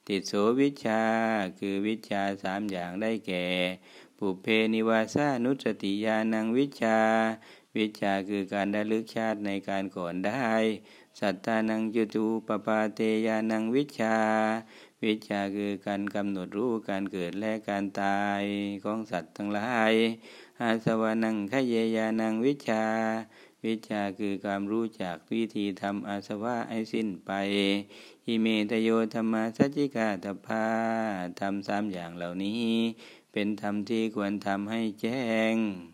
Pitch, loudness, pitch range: 110 Hz, -29 LUFS, 100-110 Hz